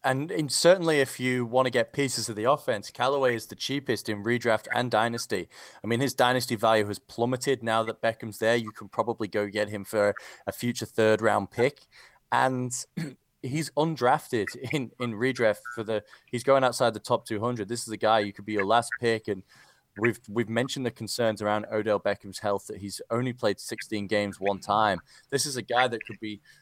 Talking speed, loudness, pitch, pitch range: 205 wpm, -27 LUFS, 115 Hz, 105-125 Hz